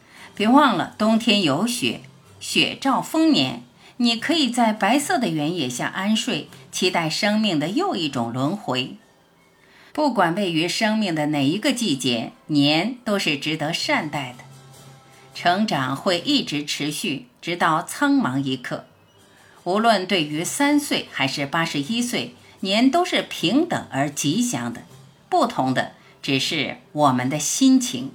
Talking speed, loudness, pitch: 205 characters per minute, -21 LUFS, 170 Hz